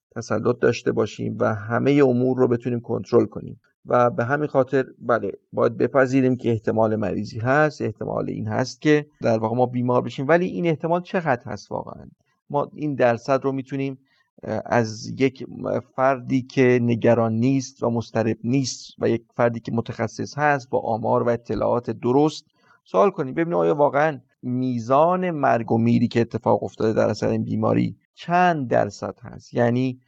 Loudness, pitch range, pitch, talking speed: -22 LUFS, 115-135 Hz, 125 Hz, 160 wpm